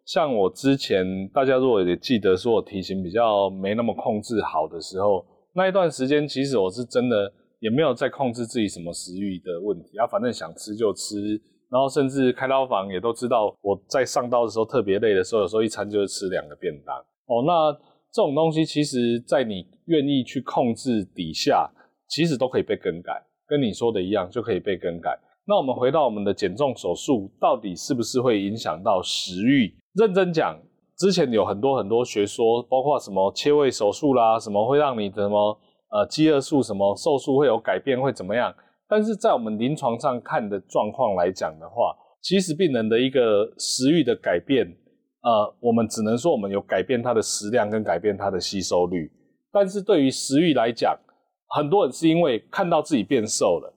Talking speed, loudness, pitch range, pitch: 305 characters per minute, -23 LUFS, 105-150 Hz, 120 Hz